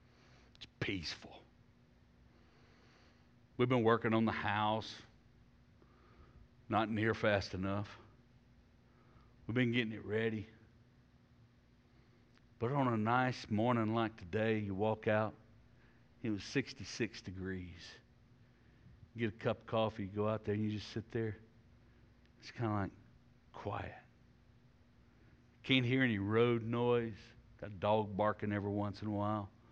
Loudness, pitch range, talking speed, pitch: -37 LUFS, 105-120 Hz, 130 wpm, 110 Hz